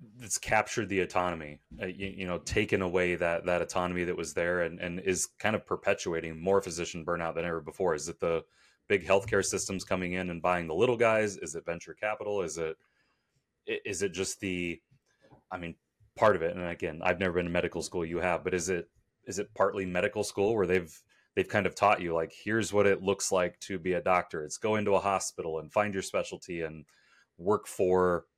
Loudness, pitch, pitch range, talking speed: -31 LUFS, 90 Hz, 85-95 Hz, 220 wpm